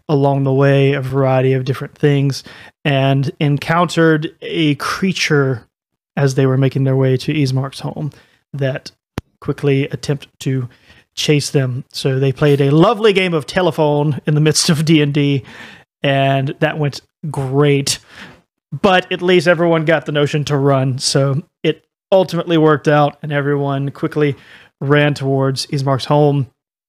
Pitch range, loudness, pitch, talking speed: 135-155 Hz, -15 LUFS, 145 Hz, 145 wpm